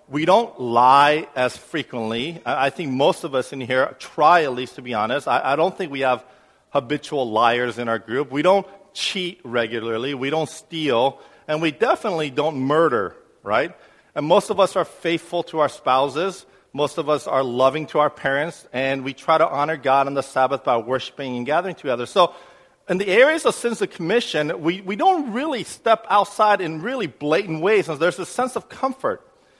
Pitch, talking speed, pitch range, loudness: 150 Hz, 195 wpm, 130-185 Hz, -21 LUFS